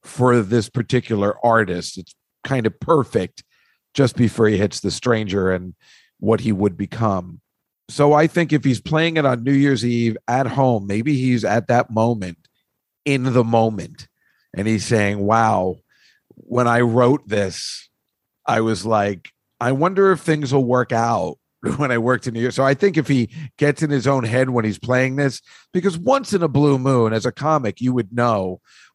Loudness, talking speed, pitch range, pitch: -19 LUFS, 185 wpm, 110-140 Hz, 120 Hz